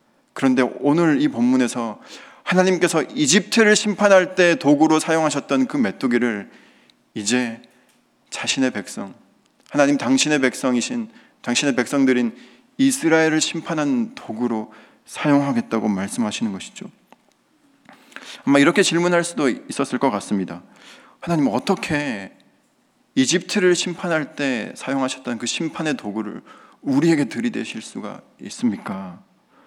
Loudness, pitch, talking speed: -20 LUFS, 165 Hz, 290 characters per minute